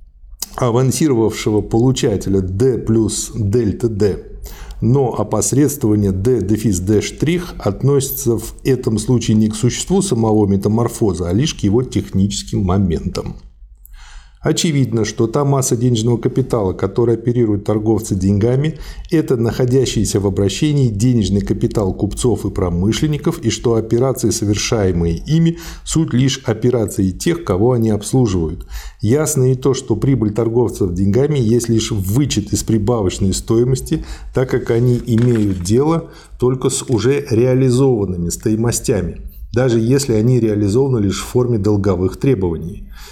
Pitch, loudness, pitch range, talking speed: 115 Hz, -16 LUFS, 100-130 Hz, 125 wpm